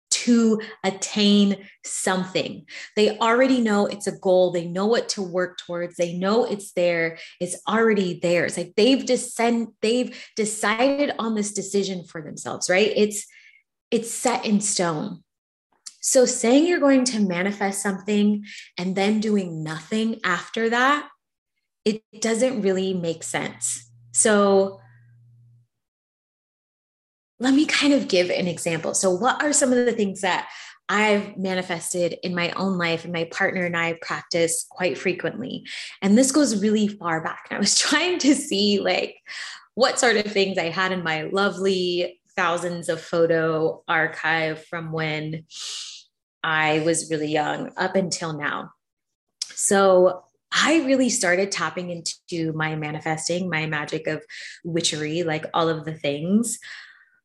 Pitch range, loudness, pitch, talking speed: 170-220 Hz, -22 LUFS, 190 Hz, 145 wpm